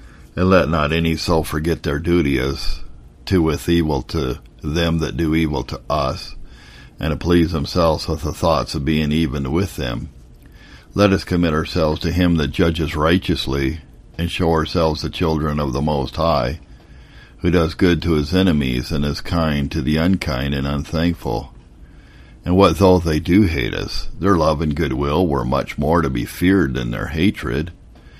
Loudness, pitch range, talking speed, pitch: -19 LUFS, 70-85 Hz, 175 wpm, 80 Hz